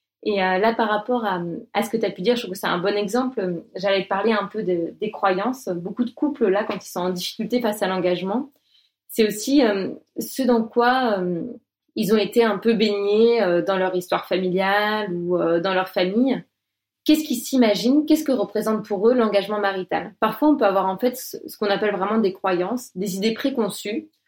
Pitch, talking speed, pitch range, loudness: 210 Hz, 215 wpm, 190-240 Hz, -22 LUFS